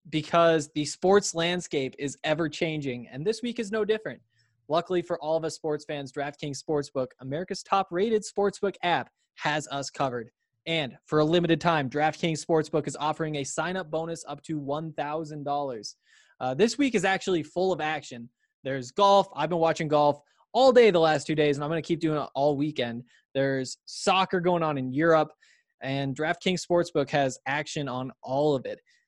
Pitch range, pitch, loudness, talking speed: 145-175 Hz, 155 Hz, -27 LUFS, 185 wpm